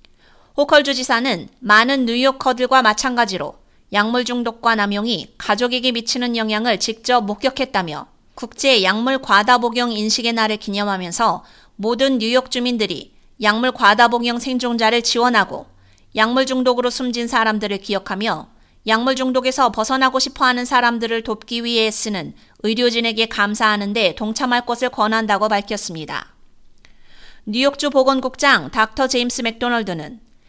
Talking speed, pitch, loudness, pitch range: 325 characters per minute, 235 Hz, -17 LUFS, 215-255 Hz